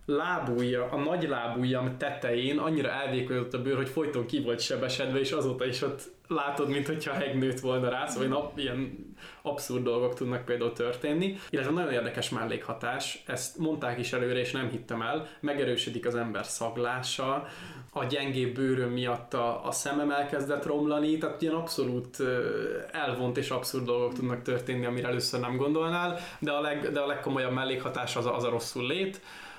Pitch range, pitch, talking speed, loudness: 125-145 Hz, 130 Hz, 165 wpm, -31 LUFS